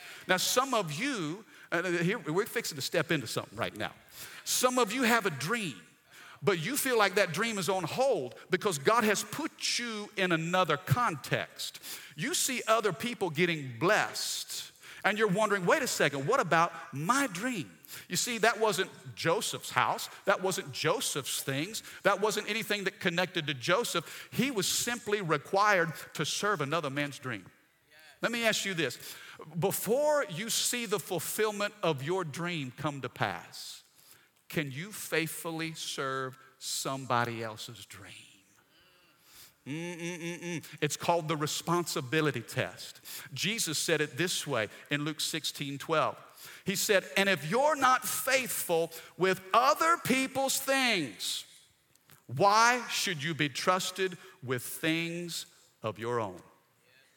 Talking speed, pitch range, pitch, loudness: 145 wpm, 155-210 Hz, 175 Hz, -30 LUFS